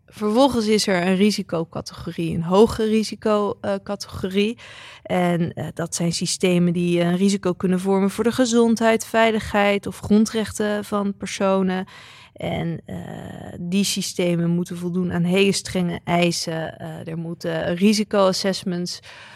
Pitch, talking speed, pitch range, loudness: 190 Hz, 125 wpm, 175-210 Hz, -21 LUFS